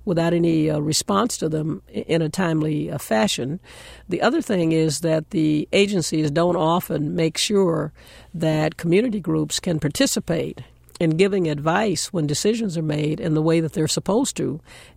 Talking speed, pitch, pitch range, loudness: 165 wpm, 165 Hz, 155-185 Hz, -21 LUFS